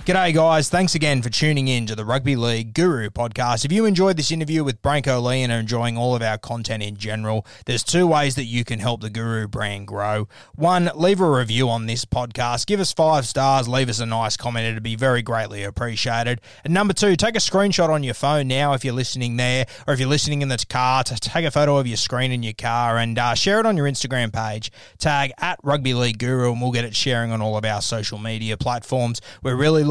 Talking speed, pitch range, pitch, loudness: 240 wpm, 115-145 Hz, 125 Hz, -21 LUFS